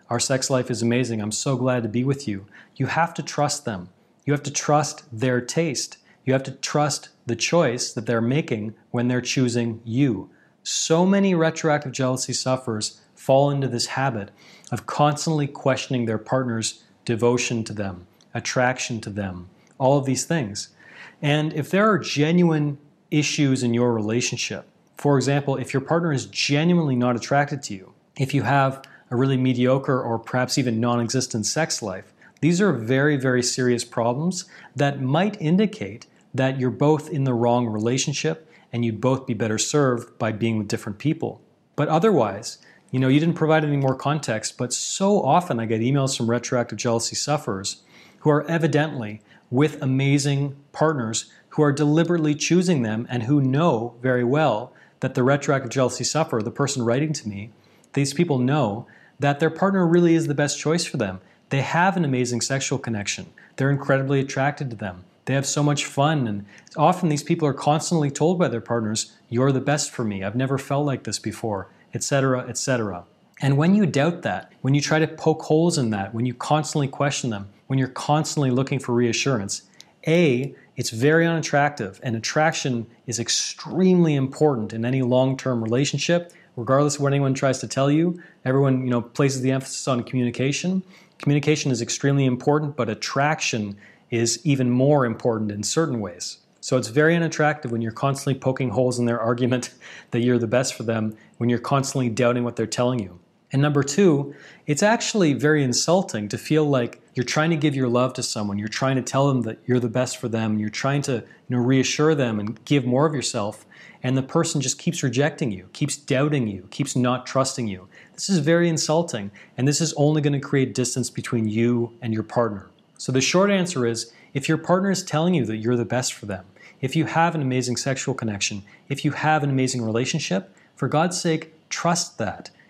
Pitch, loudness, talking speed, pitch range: 135 Hz, -22 LUFS, 190 wpm, 120-150 Hz